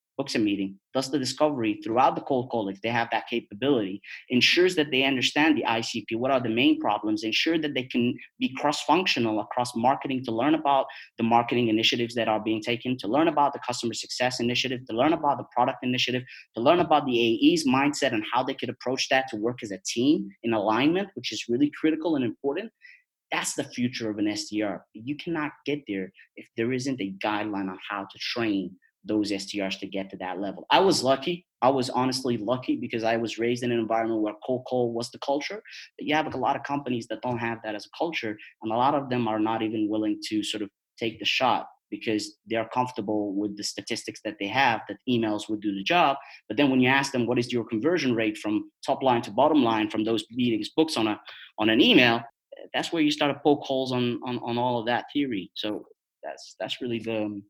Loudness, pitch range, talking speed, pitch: -26 LUFS, 110-140 Hz, 225 wpm, 125 Hz